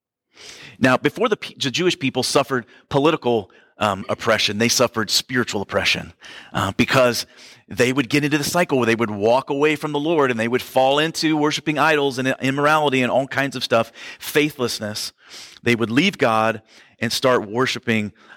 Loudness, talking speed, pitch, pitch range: -19 LUFS, 175 wpm, 125 Hz, 115-145 Hz